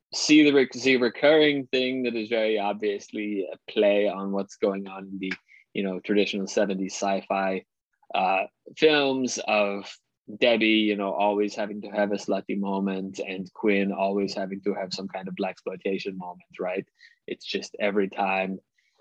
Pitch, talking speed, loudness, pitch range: 100 Hz, 160 wpm, -25 LUFS, 95-110 Hz